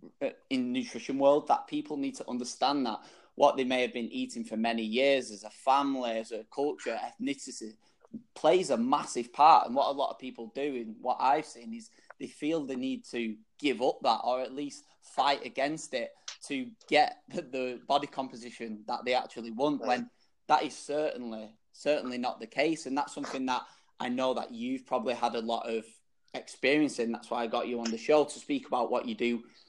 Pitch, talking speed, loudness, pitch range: 130 Hz, 205 wpm, -31 LUFS, 115-150 Hz